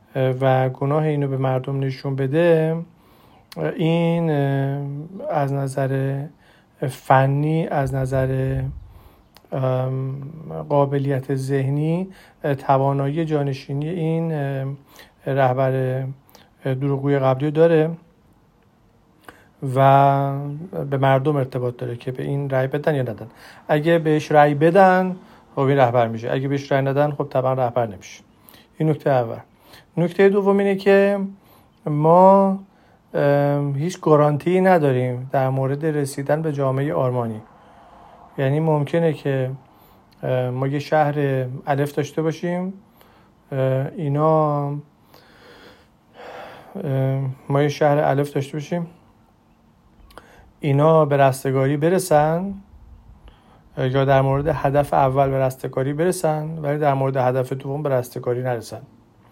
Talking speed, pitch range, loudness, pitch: 105 wpm, 135-155 Hz, -20 LUFS, 140 Hz